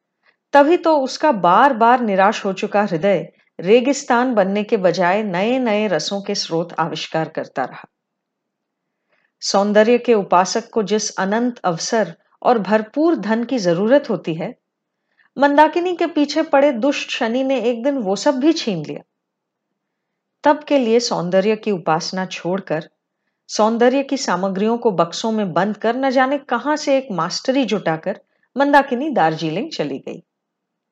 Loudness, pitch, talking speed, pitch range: -18 LUFS, 220 Hz, 145 wpm, 190-270 Hz